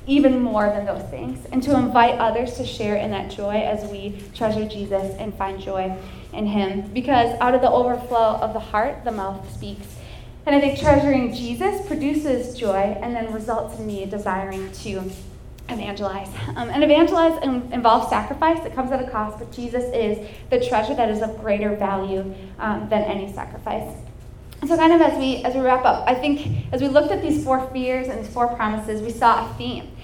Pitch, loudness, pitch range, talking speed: 225 Hz, -21 LUFS, 200-260 Hz, 200 wpm